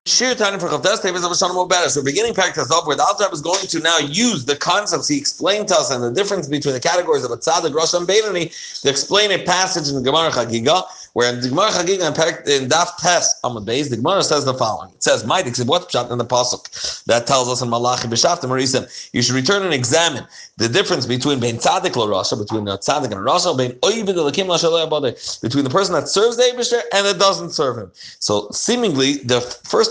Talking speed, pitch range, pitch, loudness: 210 wpm, 130-190 Hz, 165 Hz, -17 LUFS